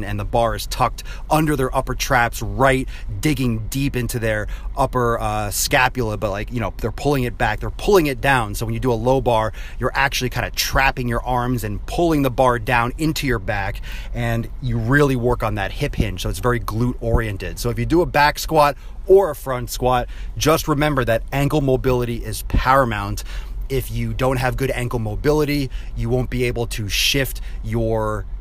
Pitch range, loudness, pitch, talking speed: 110-135 Hz, -20 LUFS, 120 Hz, 205 wpm